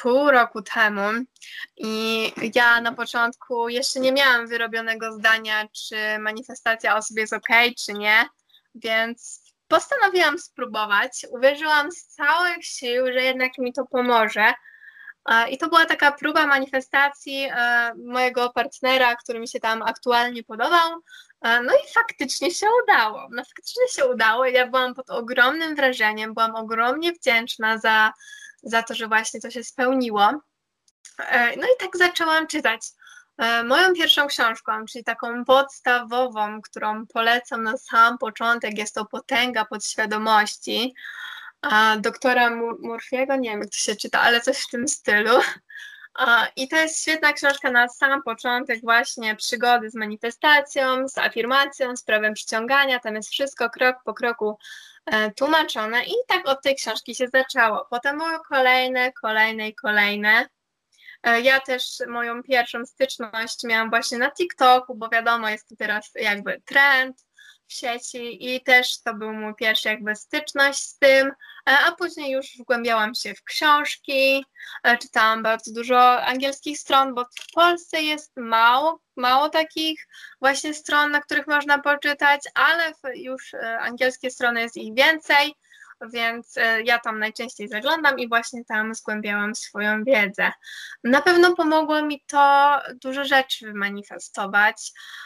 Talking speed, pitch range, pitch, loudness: 140 wpm, 225-280 Hz, 250 Hz, -21 LUFS